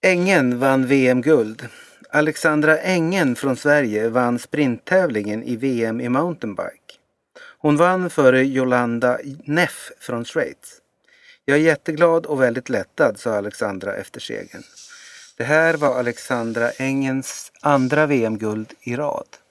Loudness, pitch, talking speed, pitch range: -19 LUFS, 135 Hz, 120 wpm, 120-155 Hz